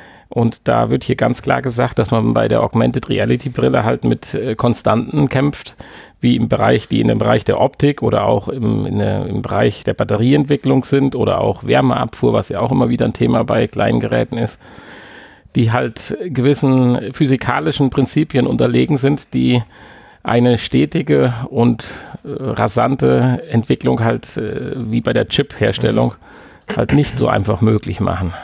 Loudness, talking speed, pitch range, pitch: -16 LUFS, 160 wpm, 105-135 Hz, 120 Hz